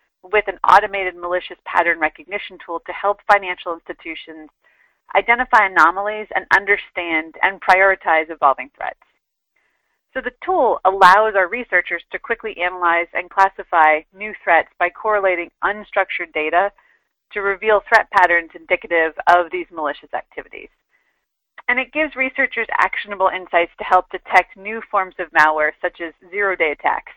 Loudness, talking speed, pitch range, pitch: -17 LUFS, 140 wpm, 175-210 Hz, 185 Hz